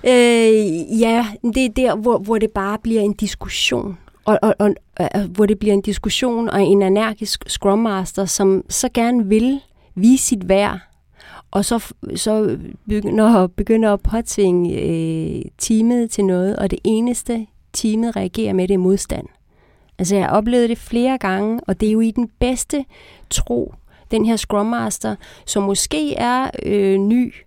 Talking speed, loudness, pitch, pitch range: 160 wpm, -18 LUFS, 215 Hz, 195-235 Hz